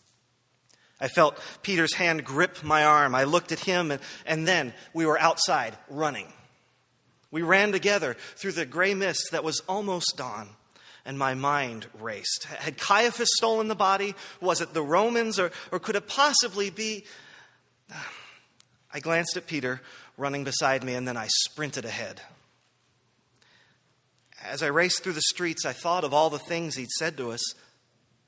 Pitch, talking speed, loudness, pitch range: 160 Hz, 160 wpm, -26 LUFS, 130-185 Hz